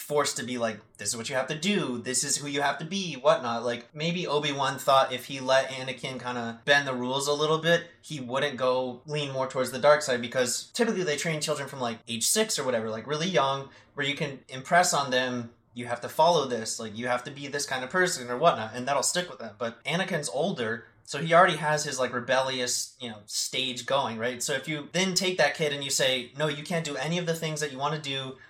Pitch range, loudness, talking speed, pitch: 125-155 Hz, -27 LUFS, 260 wpm, 135 Hz